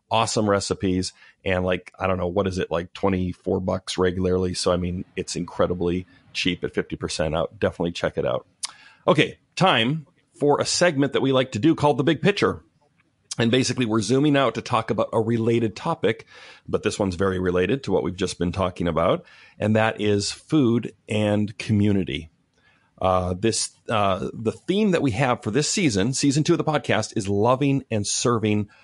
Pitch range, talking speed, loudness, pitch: 90-130 Hz, 185 wpm, -23 LUFS, 105 Hz